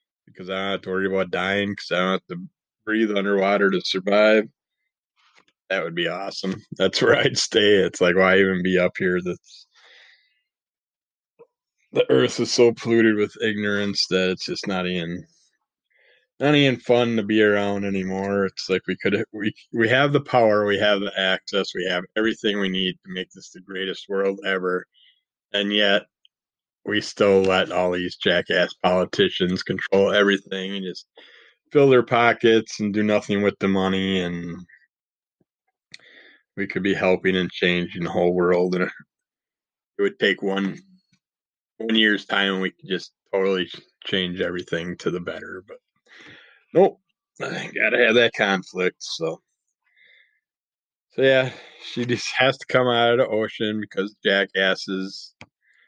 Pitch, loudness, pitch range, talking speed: 100 Hz, -21 LUFS, 95-110 Hz, 160 wpm